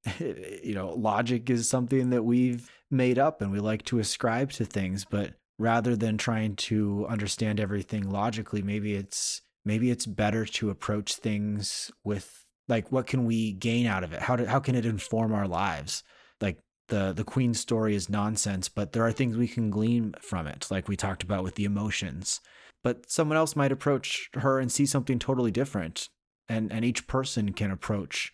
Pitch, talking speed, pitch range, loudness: 110 Hz, 190 wpm, 105-125 Hz, -29 LUFS